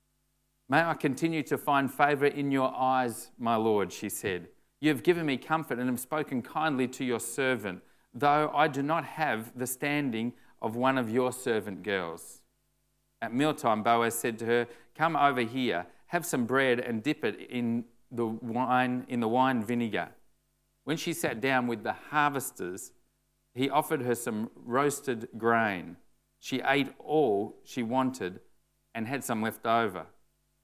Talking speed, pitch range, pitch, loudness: 165 wpm, 115-145 Hz, 125 Hz, -30 LUFS